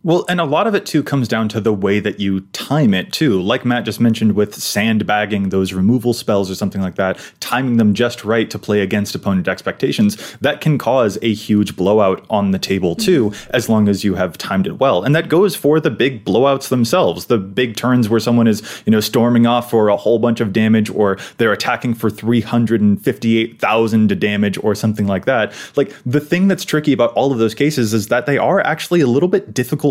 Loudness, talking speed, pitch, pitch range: -16 LUFS, 220 wpm, 115 Hz, 105-125 Hz